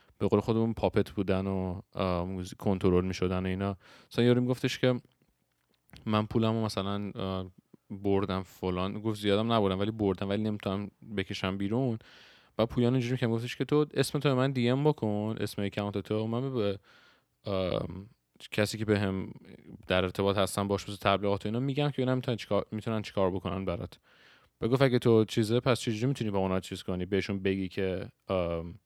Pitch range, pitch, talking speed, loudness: 95-115 Hz, 100 Hz, 160 wpm, -30 LUFS